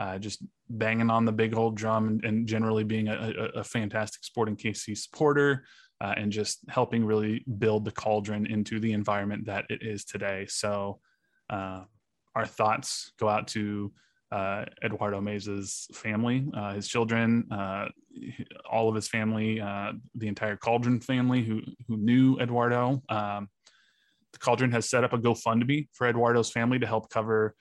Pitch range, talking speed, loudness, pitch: 105-115 Hz, 165 wpm, -29 LUFS, 110 Hz